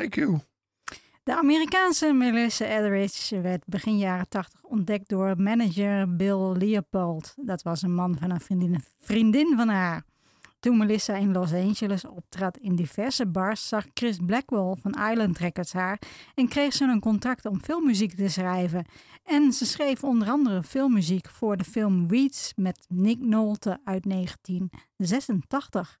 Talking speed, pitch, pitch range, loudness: 150 wpm, 200 Hz, 185-235 Hz, -26 LUFS